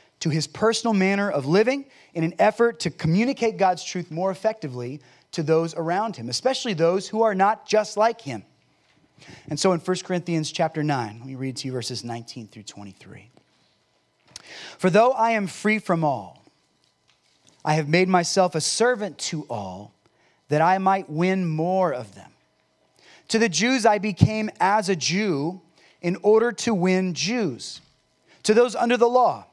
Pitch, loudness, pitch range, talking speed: 185 Hz, -23 LUFS, 155-215 Hz, 170 wpm